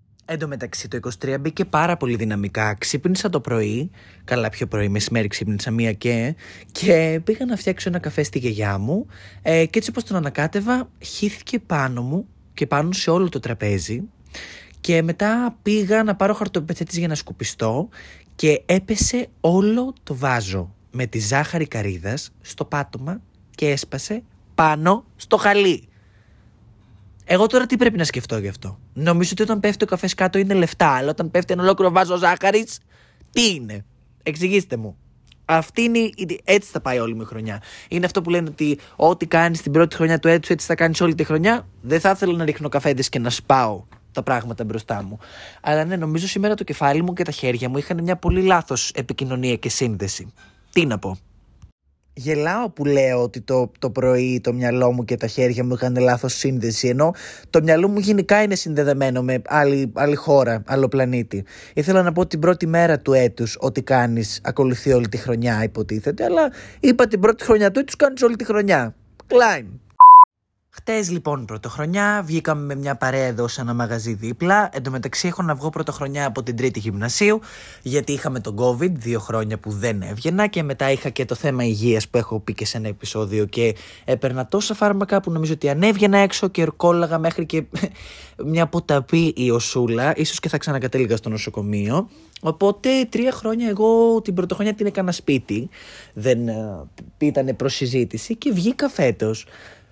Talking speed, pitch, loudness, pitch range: 180 wpm, 145 Hz, -20 LUFS, 120-180 Hz